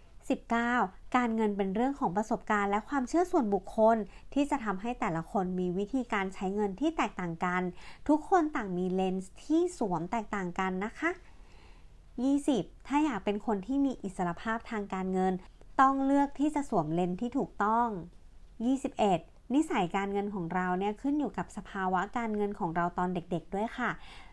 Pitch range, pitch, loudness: 190-265 Hz, 210 Hz, -31 LUFS